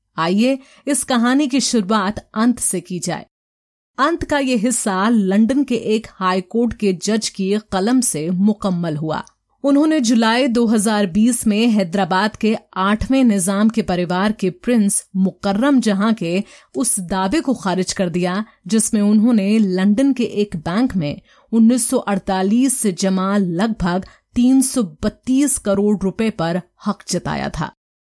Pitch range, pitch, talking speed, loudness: 190-240 Hz, 215 Hz, 135 wpm, -17 LUFS